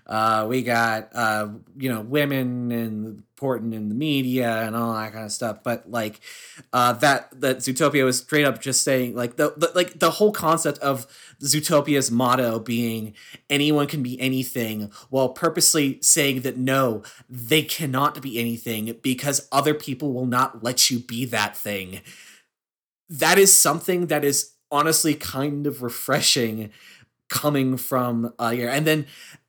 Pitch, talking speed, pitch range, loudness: 130 Hz, 155 wpm, 115-145 Hz, -21 LUFS